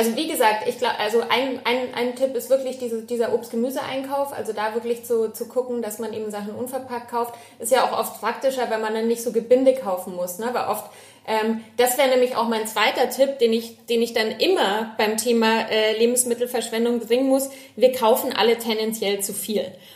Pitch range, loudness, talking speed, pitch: 225-255 Hz, -22 LUFS, 210 wpm, 235 Hz